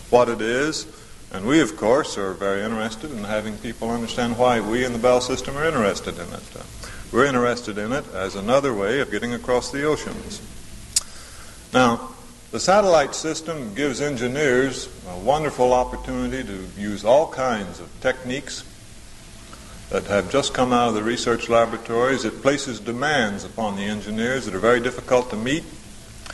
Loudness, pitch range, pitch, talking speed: -22 LUFS, 110-130 Hz, 120 Hz, 165 wpm